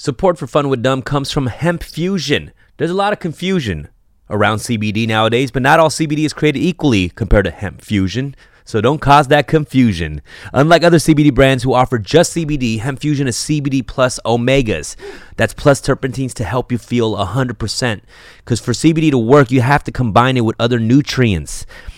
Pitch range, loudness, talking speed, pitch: 115-150 Hz, -15 LUFS, 185 wpm, 135 Hz